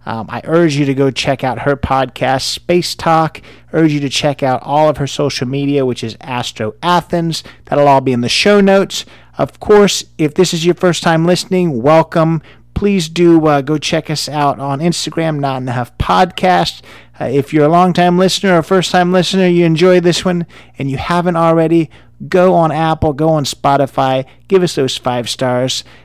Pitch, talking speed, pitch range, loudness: 155 Hz, 200 wpm, 135-175 Hz, -13 LUFS